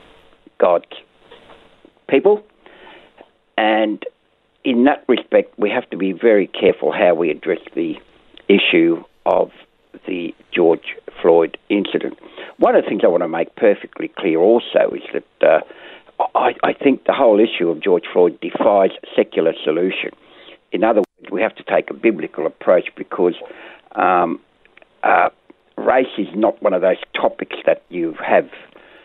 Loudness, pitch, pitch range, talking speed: -17 LUFS, 390 Hz, 335-470 Hz, 145 wpm